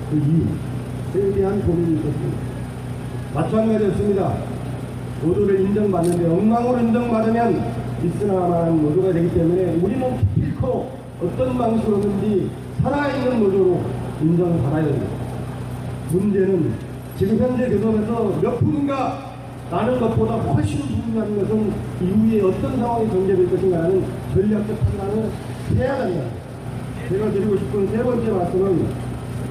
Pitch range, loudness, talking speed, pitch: 130-205 Hz, -20 LUFS, 300 characters per minute, 175 Hz